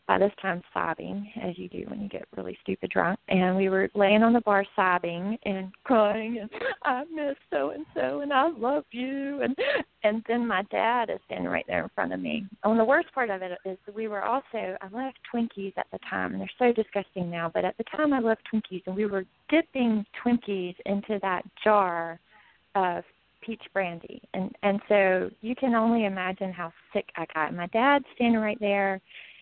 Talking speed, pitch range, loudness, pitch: 205 wpm, 190-235 Hz, -27 LUFS, 210 Hz